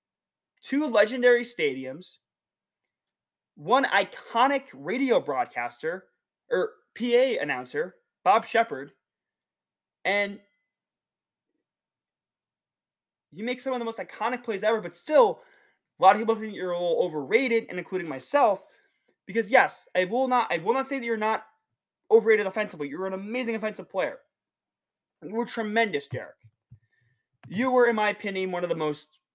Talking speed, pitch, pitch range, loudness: 140 wpm, 225 Hz, 190-250 Hz, -26 LUFS